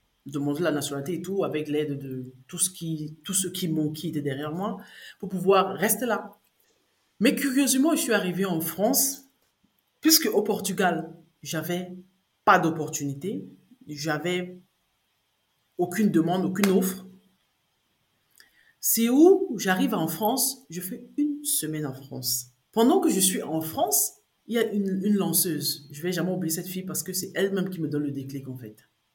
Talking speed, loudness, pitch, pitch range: 165 wpm, -25 LUFS, 180 Hz, 155-210 Hz